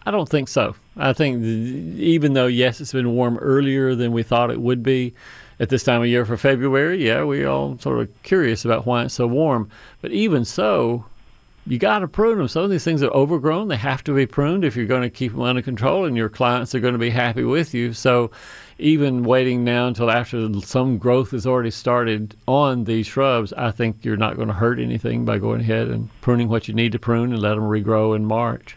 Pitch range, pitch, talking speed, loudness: 115-135 Hz, 120 Hz, 235 wpm, -20 LUFS